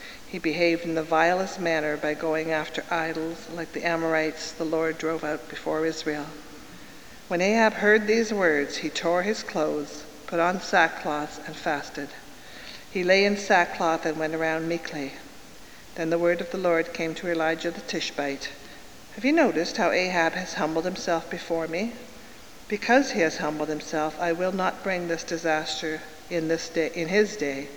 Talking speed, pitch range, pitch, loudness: 170 wpm, 155-180 Hz, 165 Hz, -26 LUFS